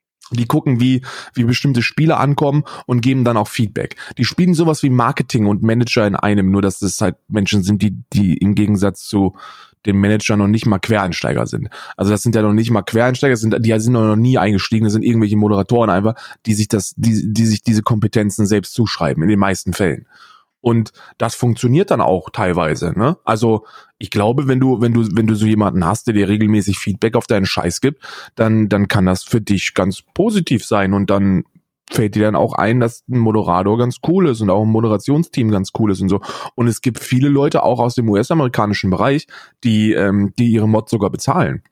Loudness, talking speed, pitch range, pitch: -16 LUFS, 210 wpm, 100-120 Hz, 110 Hz